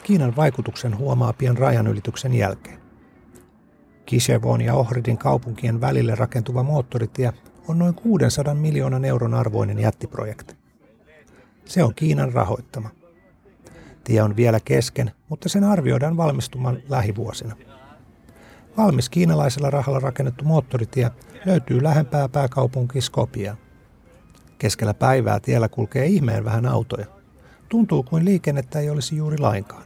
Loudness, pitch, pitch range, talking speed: -21 LUFS, 125 Hz, 115-145 Hz, 115 wpm